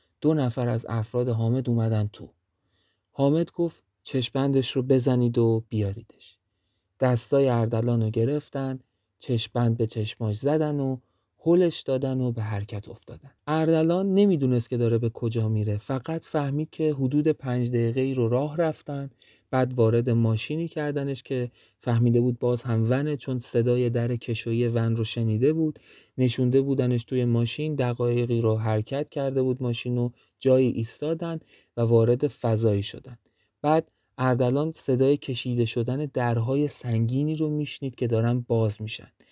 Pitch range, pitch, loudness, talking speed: 115-140 Hz, 125 Hz, -25 LUFS, 140 wpm